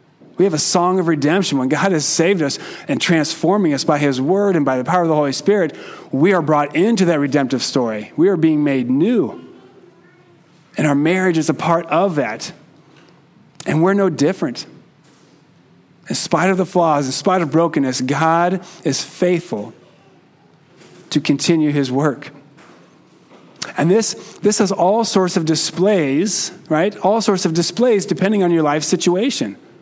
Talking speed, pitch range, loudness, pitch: 165 wpm, 150-185 Hz, -17 LUFS, 170 Hz